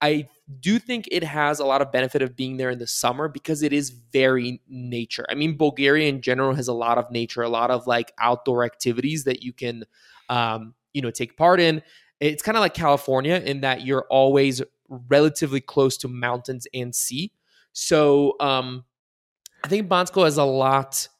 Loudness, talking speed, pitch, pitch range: -22 LUFS, 190 wpm, 135 Hz, 125-150 Hz